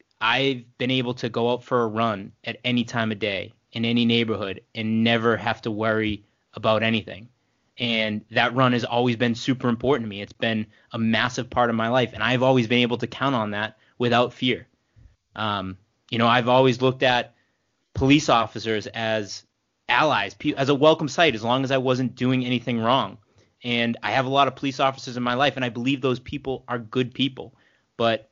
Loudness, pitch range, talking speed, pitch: -23 LUFS, 110-130 Hz, 205 wpm, 120 Hz